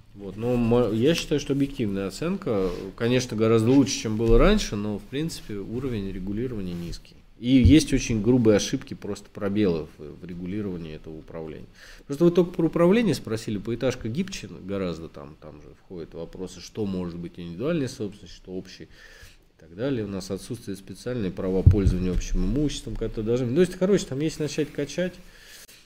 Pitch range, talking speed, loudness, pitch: 95-135 Hz, 165 wpm, -25 LUFS, 110 Hz